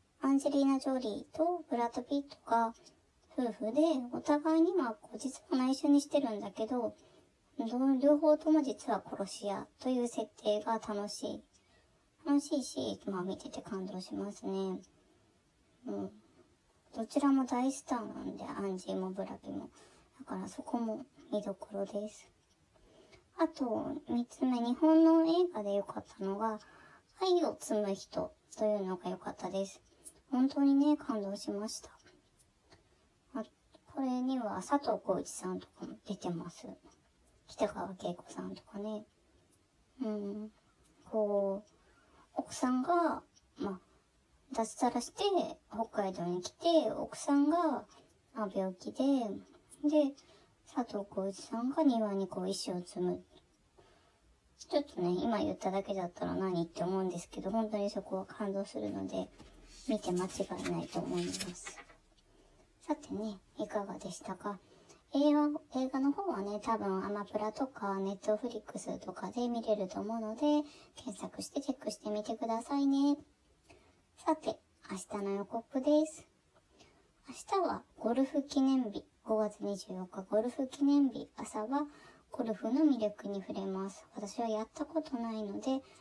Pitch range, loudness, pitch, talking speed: 200-285 Hz, -35 LUFS, 225 Hz, 265 characters per minute